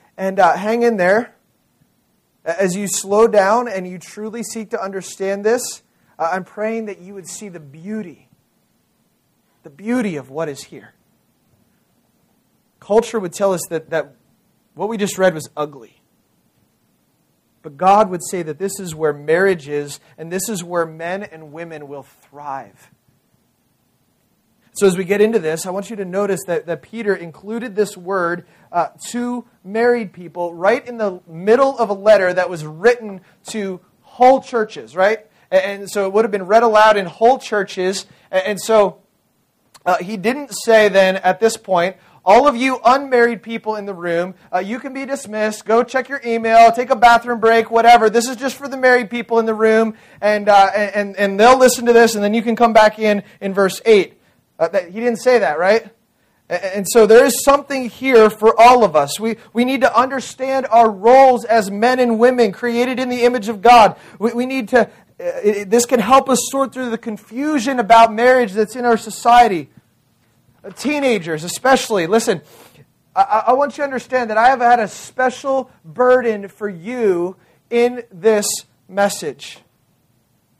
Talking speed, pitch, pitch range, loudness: 185 wpm, 215 Hz, 190-240 Hz, -16 LUFS